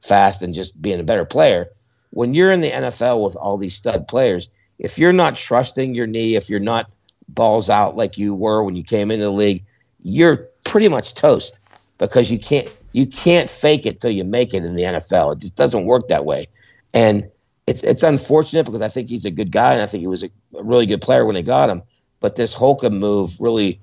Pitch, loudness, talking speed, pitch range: 110 Hz, -17 LUFS, 225 wpm, 100-130 Hz